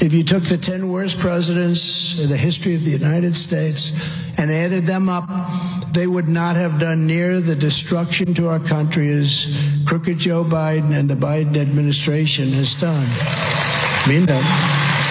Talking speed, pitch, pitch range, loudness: 160 wpm, 165 Hz, 150-175 Hz, -18 LUFS